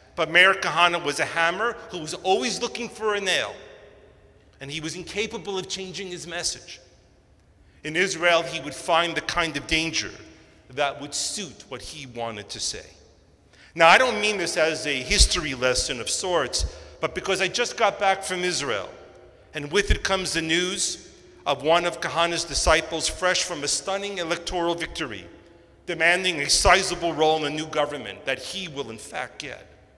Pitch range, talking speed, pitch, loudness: 150-185 Hz, 175 wpm, 170 Hz, -23 LUFS